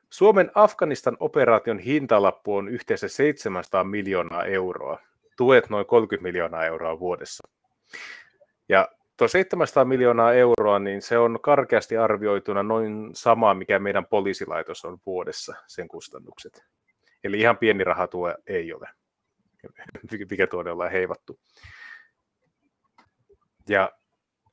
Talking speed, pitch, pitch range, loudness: 110 wpm, 110 Hz, 95-135 Hz, -22 LUFS